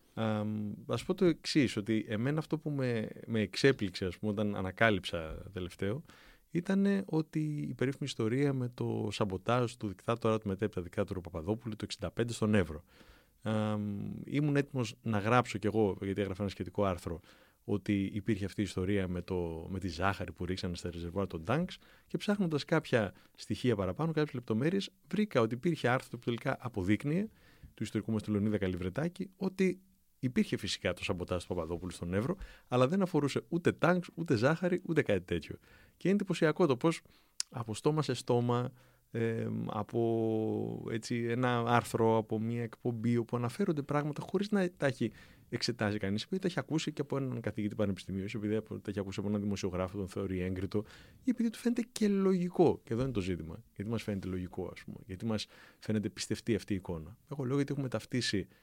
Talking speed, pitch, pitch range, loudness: 180 wpm, 115 Hz, 100-140 Hz, -34 LUFS